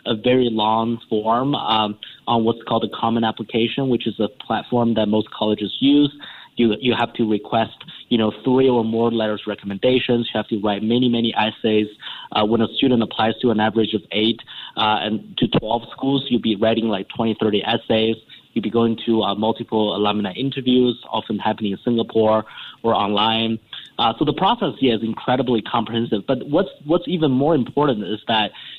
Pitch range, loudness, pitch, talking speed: 110-120 Hz, -20 LUFS, 115 Hz, 190 wpm